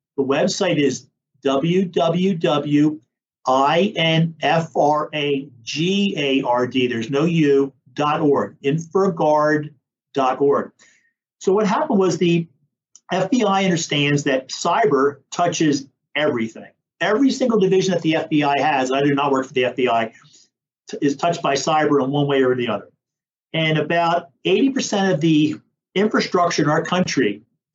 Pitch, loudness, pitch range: 150 Hz, -19 LUFS, 140-175 Hz